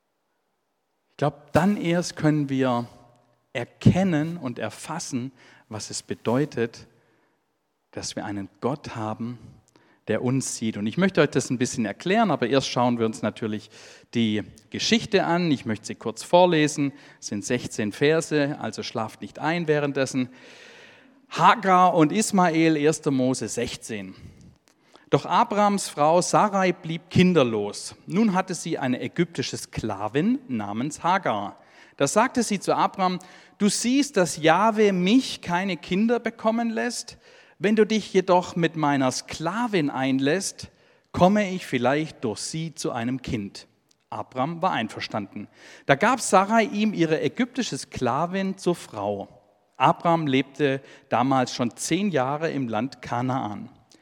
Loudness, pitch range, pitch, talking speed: -24 LUFS, 125-185 Hz, 150 Hz, 135 wpm